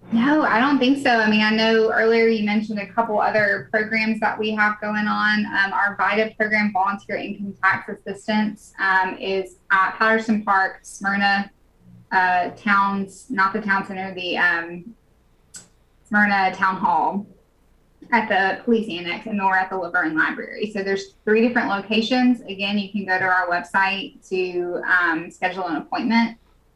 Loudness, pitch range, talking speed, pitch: -20 LUFS, 190-220 Hz, 165 wpm, 200 Hz